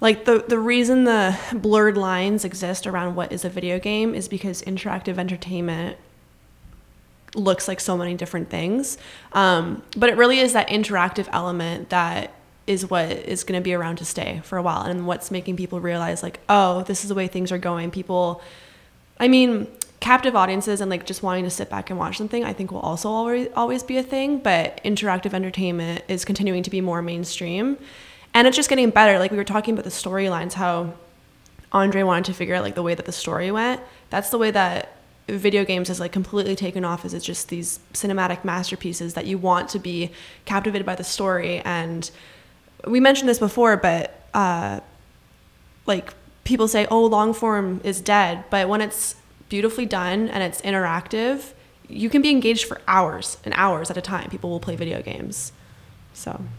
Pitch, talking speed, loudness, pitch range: 190 Hz, 195 wpm, -22 LUFS, 175-215 Hz